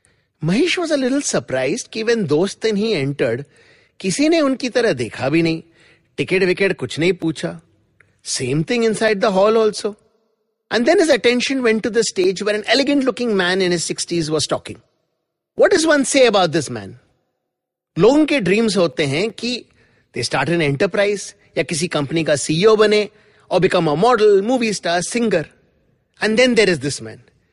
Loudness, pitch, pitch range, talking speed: -17 LUFS, 200 Hz, 165-230 Hz, 155 wpm